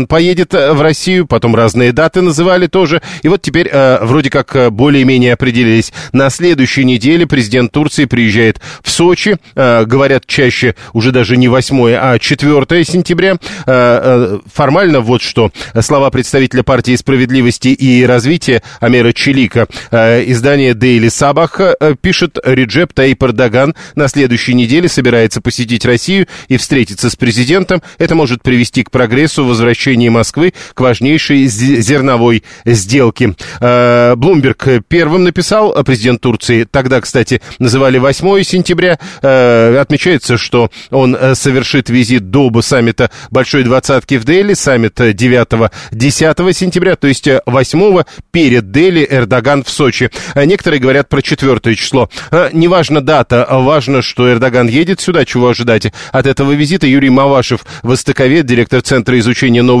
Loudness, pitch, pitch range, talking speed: -9 LUFS, 130 Hz, 120-155 Hz, 135 wpm